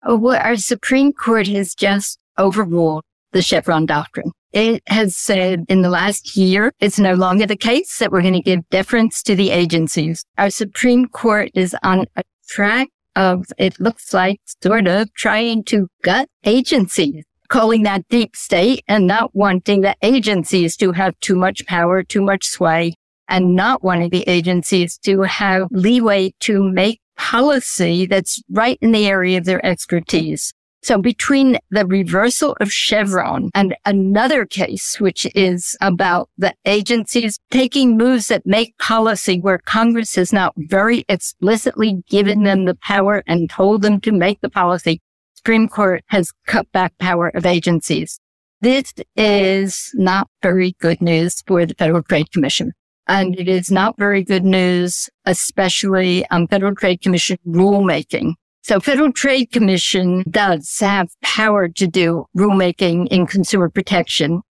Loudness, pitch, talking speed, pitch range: -16 LUFS, 195 Hz, 155 wpm, 180-220 Hz